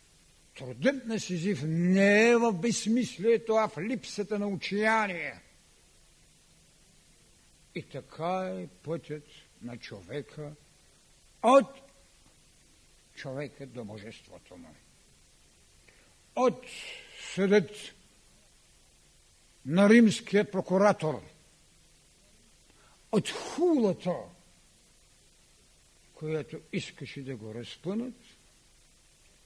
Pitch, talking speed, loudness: 170 Hz, 70 wpm, -28 LUFS